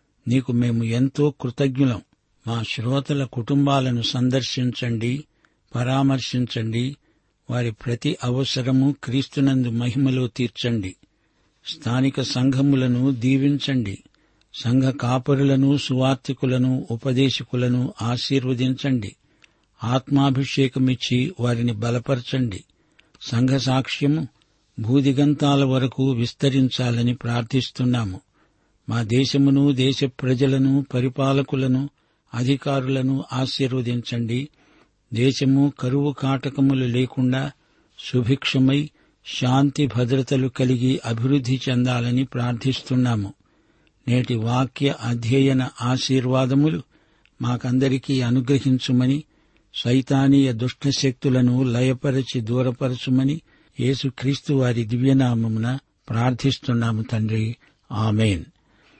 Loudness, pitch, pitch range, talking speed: -22 LUFS, 130 Hz, 120-135 Hz, 65 wpm